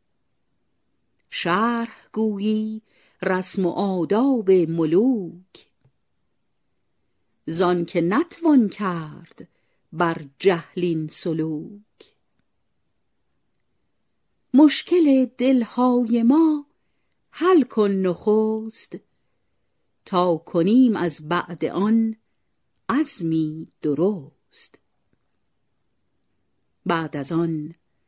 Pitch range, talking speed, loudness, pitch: 170-235 Hz, 60 wpm, -21 LUFS, 190 Hz